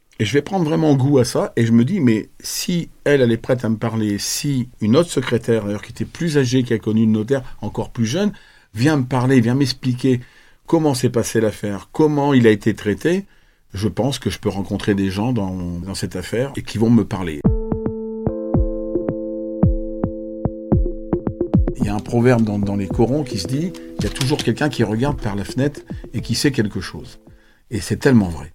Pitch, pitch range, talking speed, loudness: 115 Hz, 105-135 Hz, 210 wpm, -19 LUFS